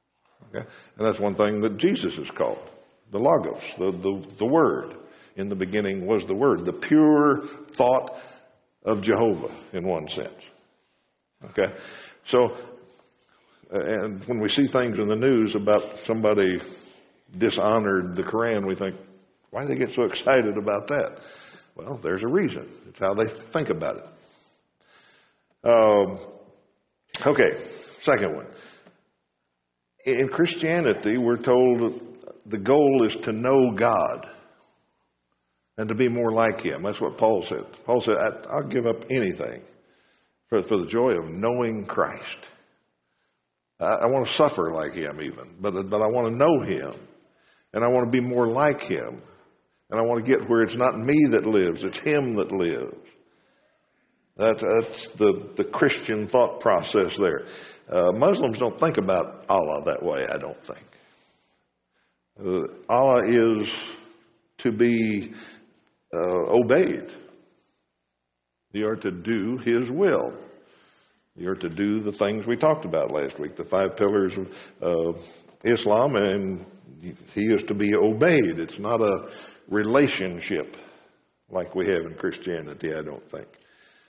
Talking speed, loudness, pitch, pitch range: 145 wpm, -24 LUFS, 110 Hz, 95-125 Hz